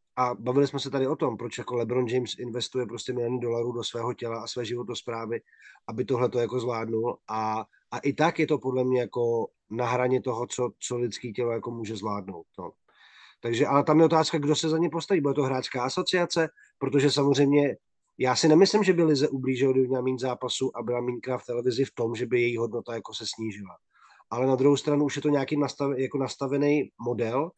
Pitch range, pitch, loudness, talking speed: 120-140 Hz, 125 Hz, -27 LUFS, 210 wpm